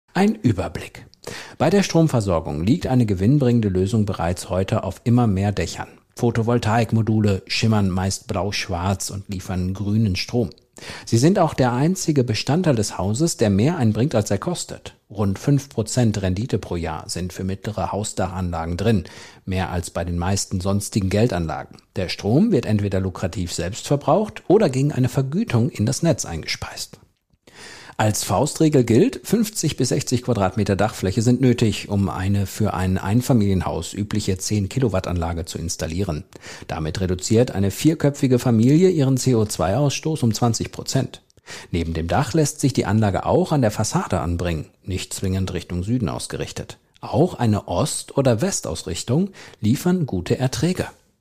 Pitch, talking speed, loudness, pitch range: 110 Hz, 145 wpm, -21 LUFS, 95-125 Hz